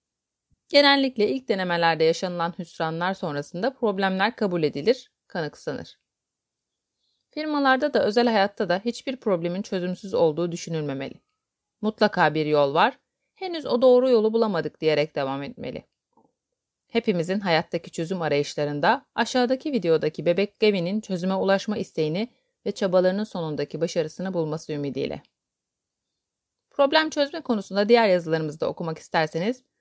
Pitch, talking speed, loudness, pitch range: 190 Hz, 115 wpm, -24 LUFS, 160-230 Hz